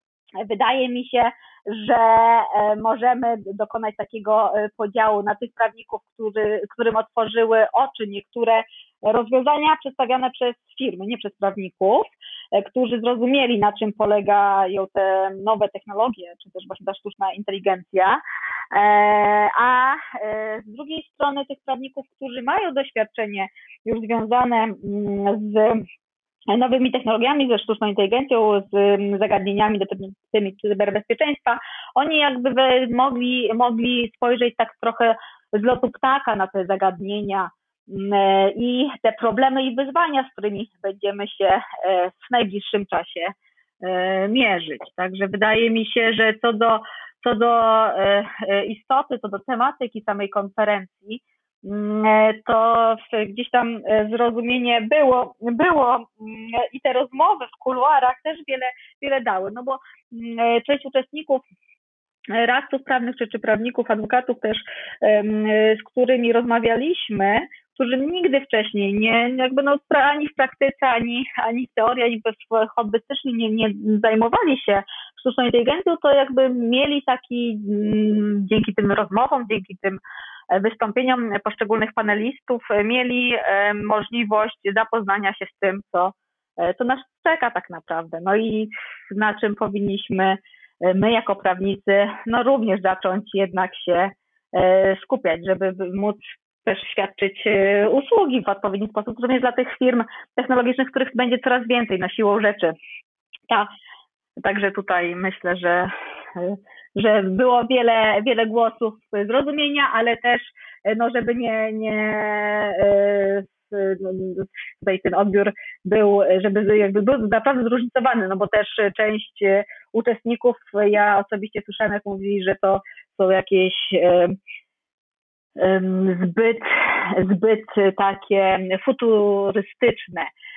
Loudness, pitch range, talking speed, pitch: -20 LUFS, 200-250 Hz, 115 wpm, 220 Hz